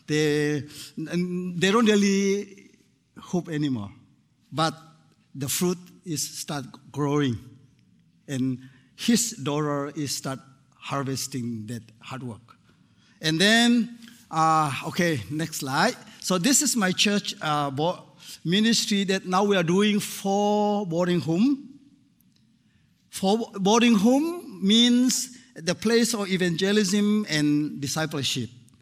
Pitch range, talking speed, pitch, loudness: 145-210 Hz, 110 wpm, 175 Hz, -24 LUFS